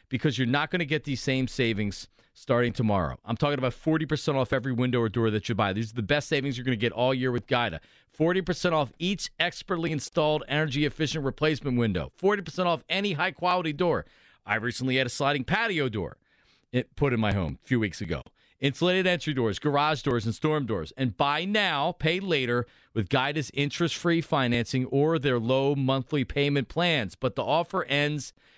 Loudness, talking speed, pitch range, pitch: -27 LUFS, 195 wpm, 120-155 Hz, 140 Hz